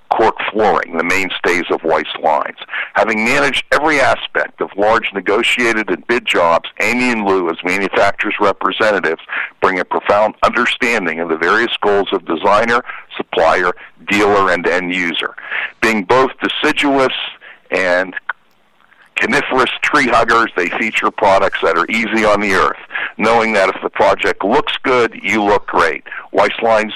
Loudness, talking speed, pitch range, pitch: -14 LUFS, 145 wpm, 95-115 Hz, 105 Hz